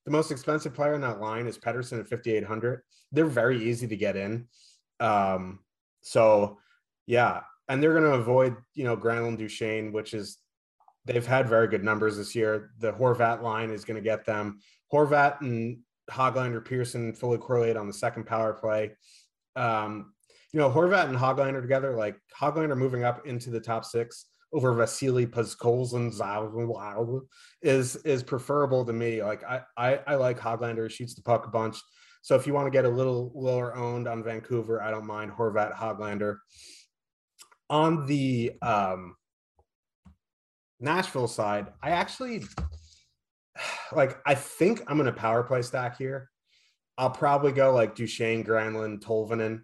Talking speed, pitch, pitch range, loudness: 160 wpm, 115 Hz, 110-130 Hz, -28 LUFS